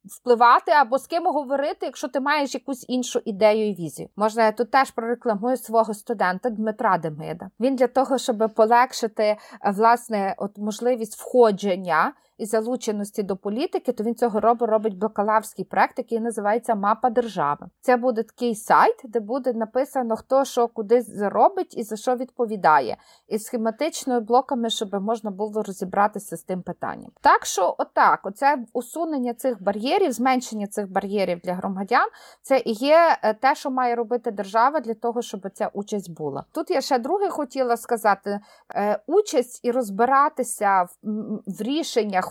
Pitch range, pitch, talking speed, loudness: 210-255 Hz, 230 Hz, 155 wpm, -23 LUFS